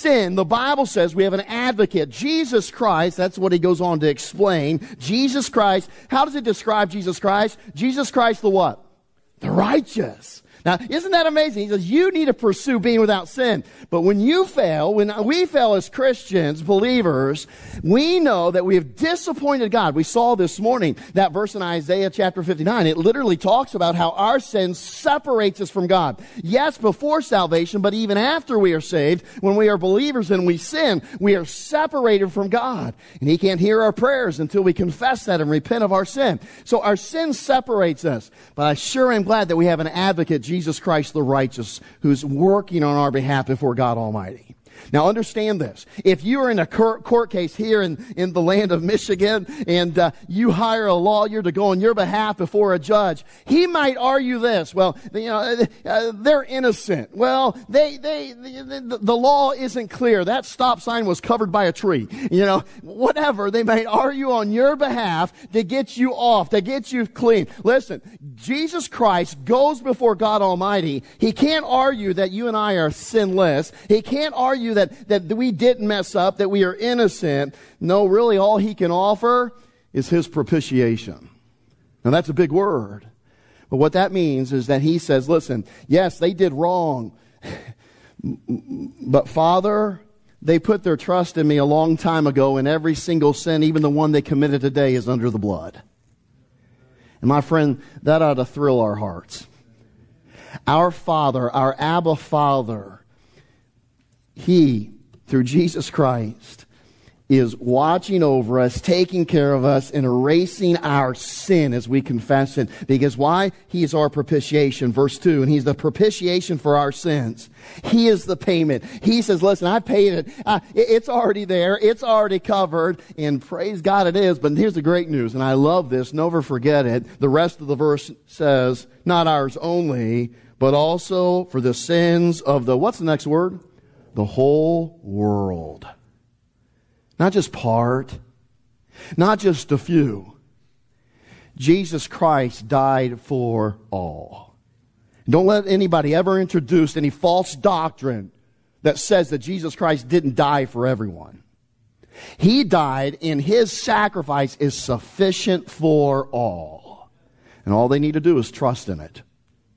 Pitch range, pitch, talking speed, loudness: 140-210 Hz, 175 Hz, 170 wpm, -19 LUFS